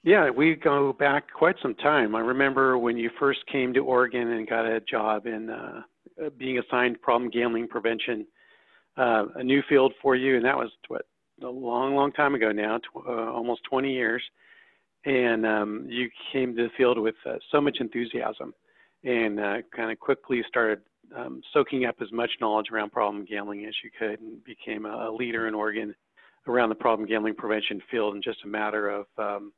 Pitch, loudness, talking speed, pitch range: 120 Hz, -26 LUFS, 195 wpm, 110-130 Hz